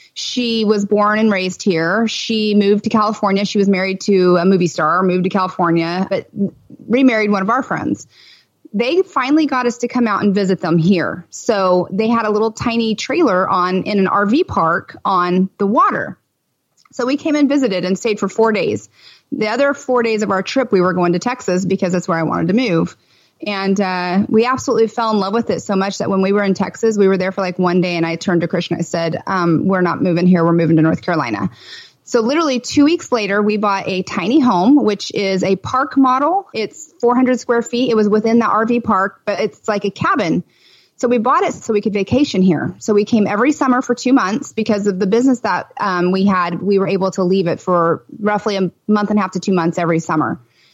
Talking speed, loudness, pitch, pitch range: 230 wpm, -16 LUFS, 205 Hz, 185-235 Hz